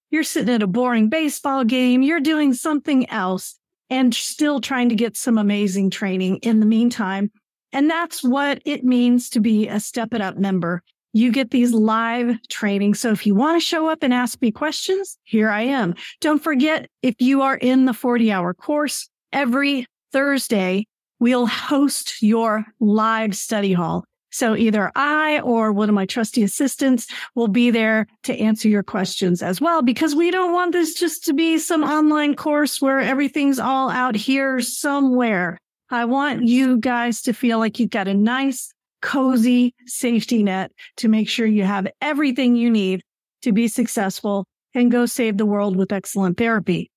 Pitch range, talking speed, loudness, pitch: 215-275 Hz, 180 wpm, -19 LUFS, 245 Hz